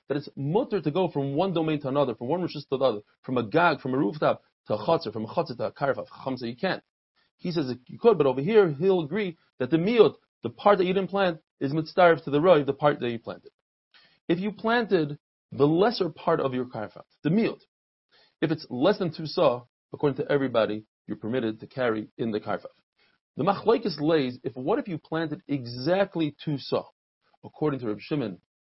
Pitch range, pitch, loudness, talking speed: 125-185 Hz, 150 Hz, -26 LUFS, 210 wpm